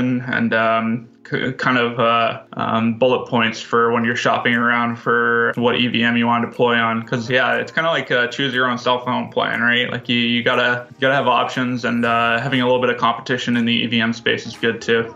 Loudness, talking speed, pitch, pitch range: -18 LUFS, 230 wpm, 120 Hz, 115-125 Hz